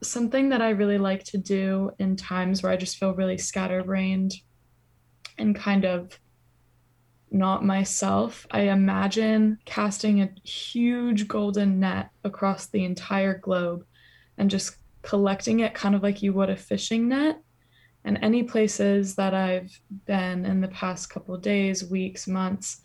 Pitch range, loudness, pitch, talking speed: 185-205 Hz, -25 LUFS, 195 Hz, 150 wpm